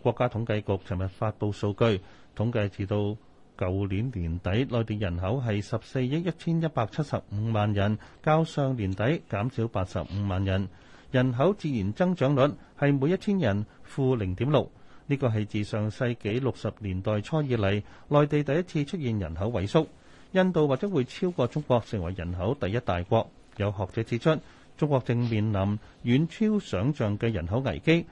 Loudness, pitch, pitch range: -28 LUFS, 115 Hz, 100-135 Hz